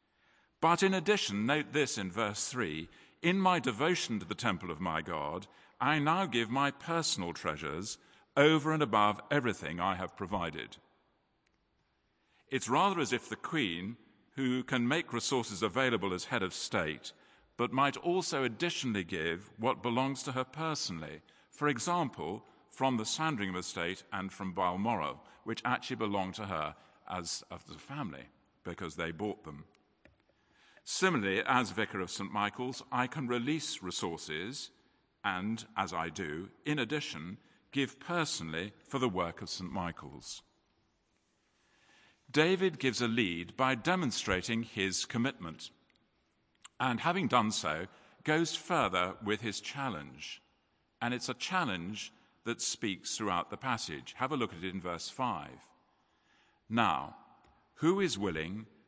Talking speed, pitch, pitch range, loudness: 140 wpm, 120 Hz, 100-145 Hz, -34 LUFS